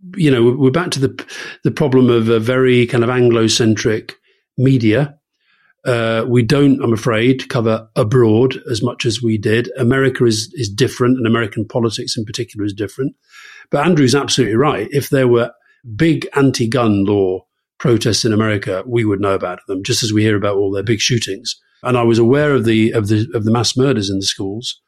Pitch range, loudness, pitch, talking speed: 110-130 Hz, -15 LUFS, 120 Hz, 195 wpm